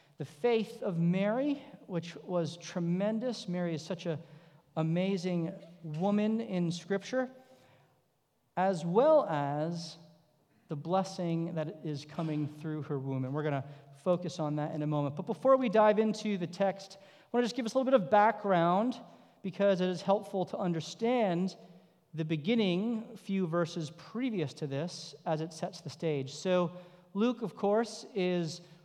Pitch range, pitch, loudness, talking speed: 160-210 Hz, 180 Hz, -32 LUFS, 160 wpm